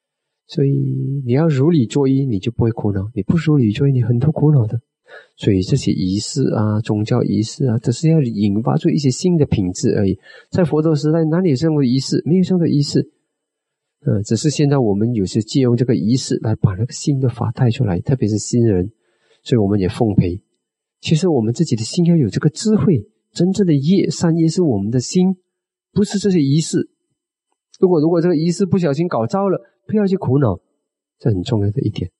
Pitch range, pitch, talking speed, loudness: 115-165 Hz, 135 Hz, 310 characters per minute, -17 LUFS